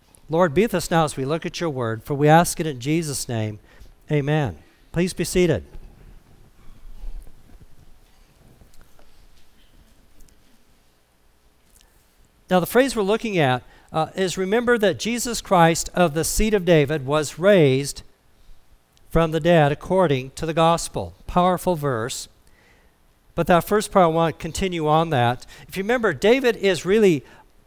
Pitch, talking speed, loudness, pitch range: 160 Hz, 145 wpm, -21 LUFS, 120-185 Hz